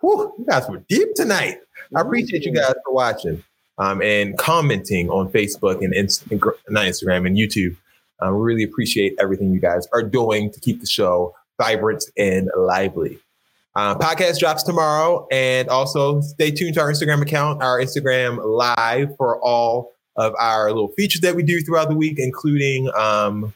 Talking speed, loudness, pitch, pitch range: 170 wpm, -19 LUFS, 125 Hz, 105-155 Hz